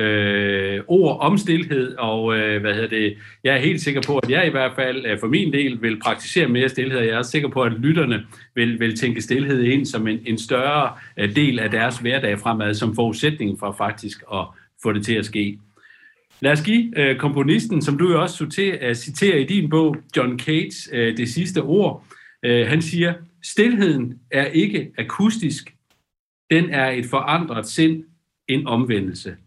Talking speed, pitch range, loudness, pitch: 175 wpm, 115-160 Hz, -20 LUFS, 130 Hz